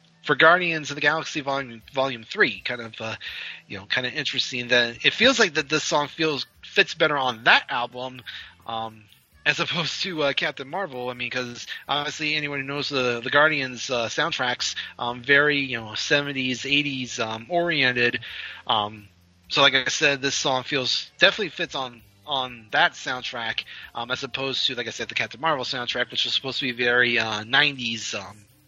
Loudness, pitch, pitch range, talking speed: -23 LUFS, 130 Hz, 120-145 Hz, 185 wpm